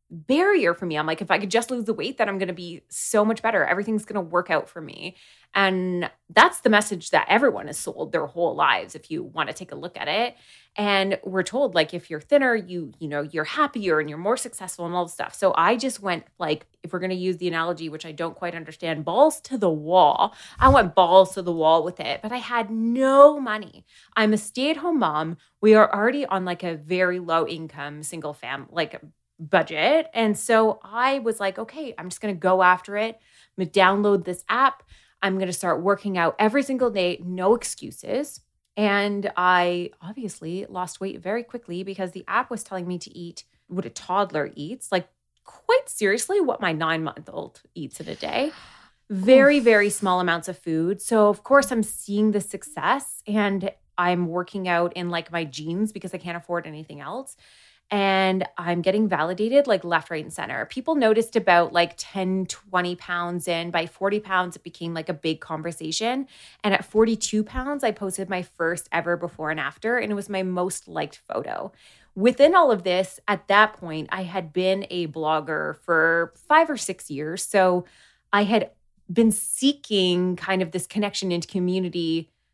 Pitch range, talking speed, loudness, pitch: 175-215 Hz, 205 wpm, -23 LUFS, 190 Hz